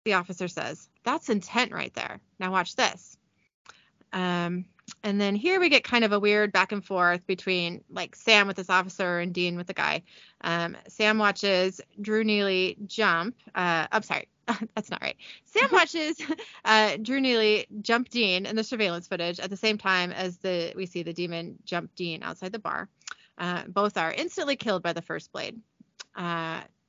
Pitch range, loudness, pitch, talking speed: 180-220 Hz, -27 LUFS, 195 Hz, 185 wpm